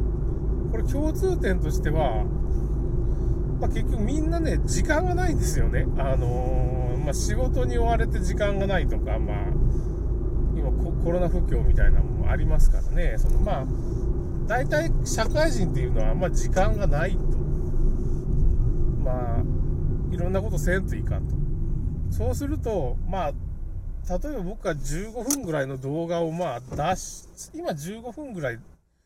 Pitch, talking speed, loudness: 125 Hz, 275 characters per minute, -27 LUFS